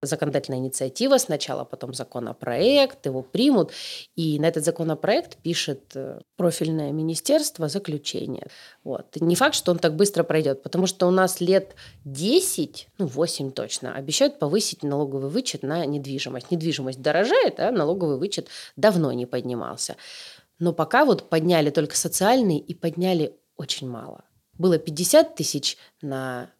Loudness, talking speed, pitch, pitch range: -23 LUFS, 135 wpm, 160 Hz, 140-185 Hz